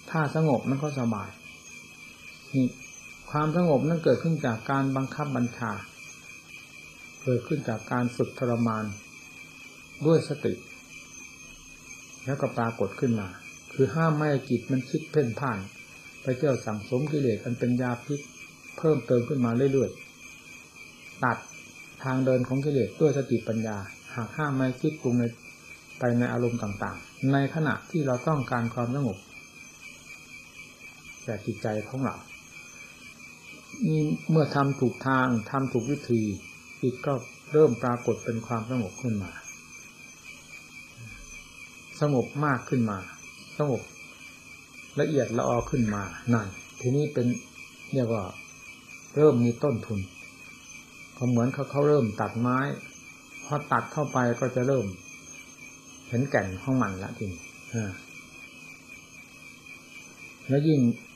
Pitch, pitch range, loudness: 125 Hz, 110-135 Hz, -28 LUFS